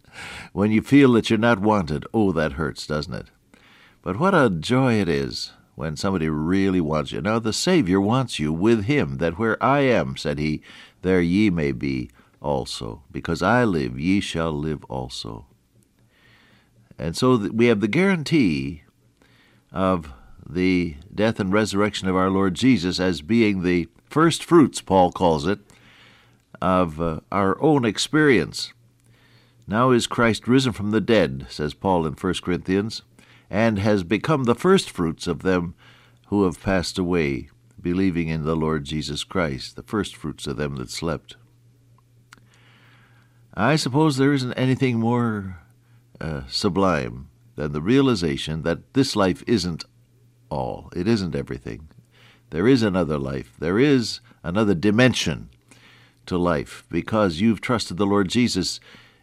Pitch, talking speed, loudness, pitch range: 100 Hz, 145 wpm, -22 LUFS, 85-120 Hz